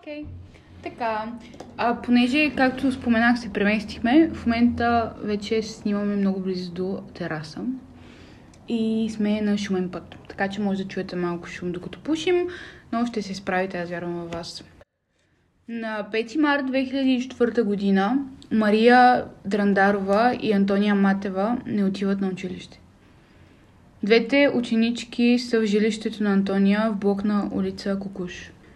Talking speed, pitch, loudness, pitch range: 135 wpm, 215 Hz, -23 LUFS, 195-240 Hz